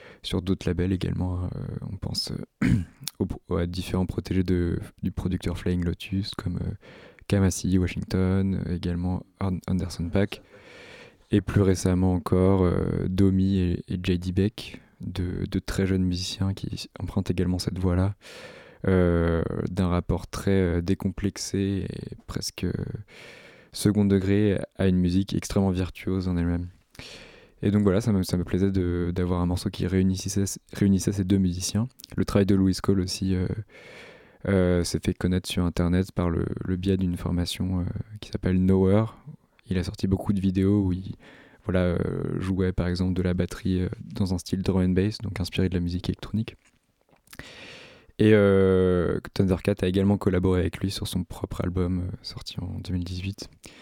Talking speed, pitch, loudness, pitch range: 160 wpm, 95 Hz, -26 LUFS, 90-100 Hz